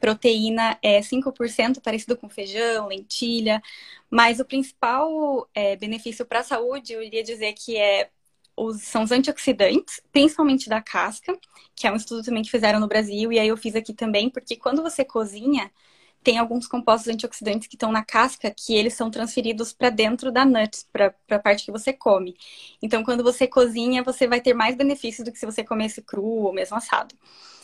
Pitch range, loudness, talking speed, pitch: 220-255 Hz, -22 LUFS, 185 wpm, 230 Hz